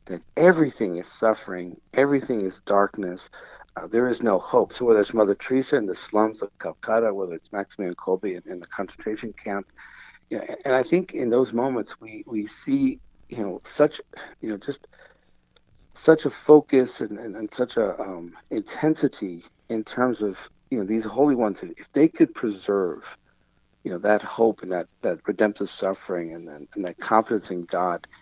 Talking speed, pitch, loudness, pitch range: 180 wpm, 110 Hz, -24 LUFS, 100-135 Hz